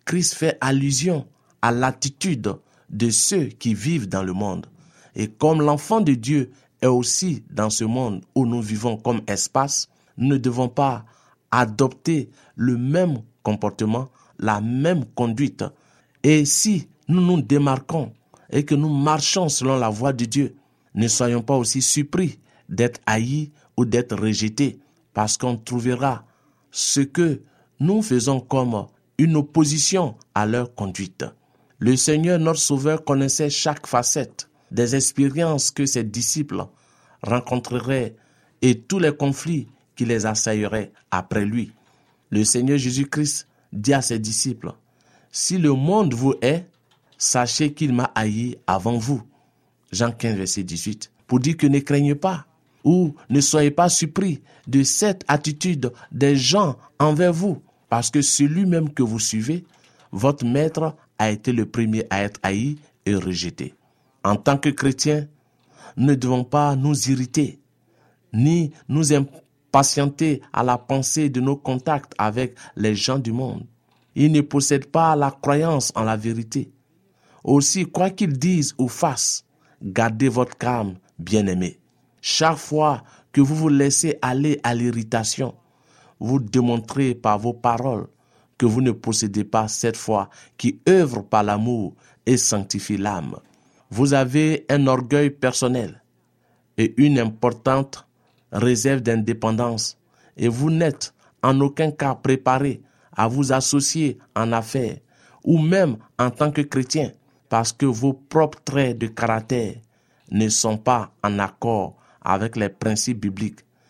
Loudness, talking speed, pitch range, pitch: -21 LUFS, 140 wpm, 115-145 Hz, 130 Hz